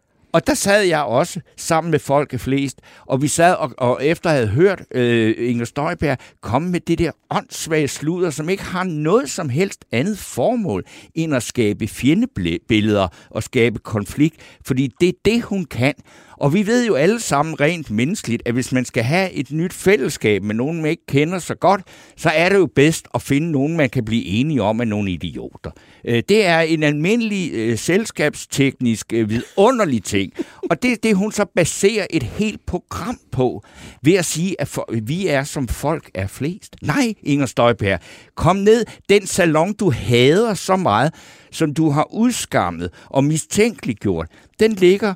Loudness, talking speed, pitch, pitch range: -18 LUFS, 180 wpm, 150 Hz, 120-180 Hz